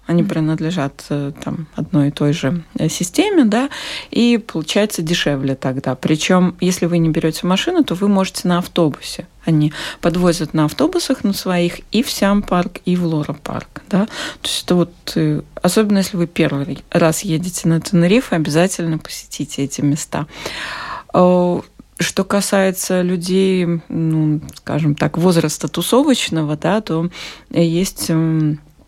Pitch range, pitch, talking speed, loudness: 155-190 Hz, 170 Hz, 135 wpm, -17 LUFS